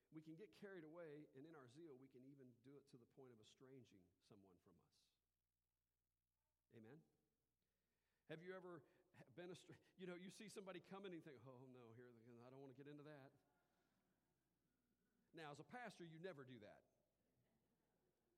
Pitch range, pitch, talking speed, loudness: 120-175 Hz, 140 Hz, 180 wpm, -62 LUFS